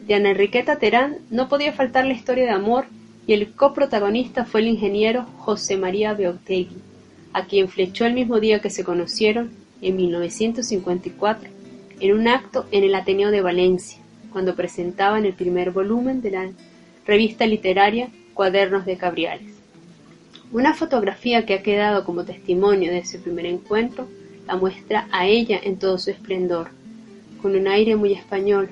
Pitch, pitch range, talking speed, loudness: 205 Hz, 190-225 Hz, 155 wpm, -21 LUFS